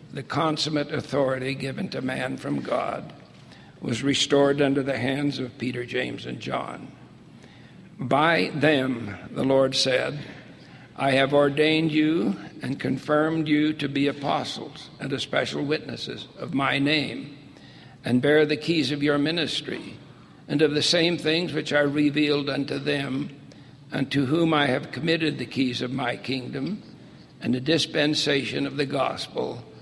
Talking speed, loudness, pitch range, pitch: 145 wpm, -24 LUFS, 135-150 Hz, 140 Hz